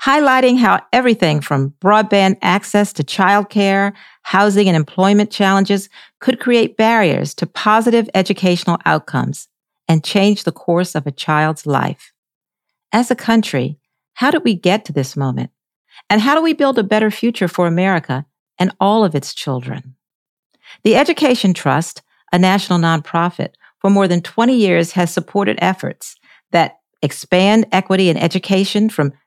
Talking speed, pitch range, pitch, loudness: 150 wpm, 165-215 Hz, 190 Hz, -15 LUFS